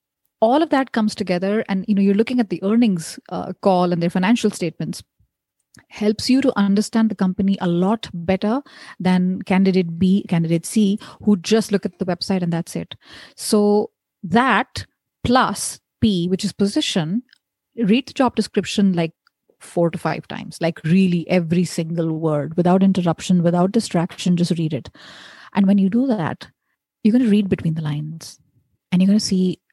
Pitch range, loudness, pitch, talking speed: 175-215 Hz, -19 LUFS, 190 Hz, 175 wpm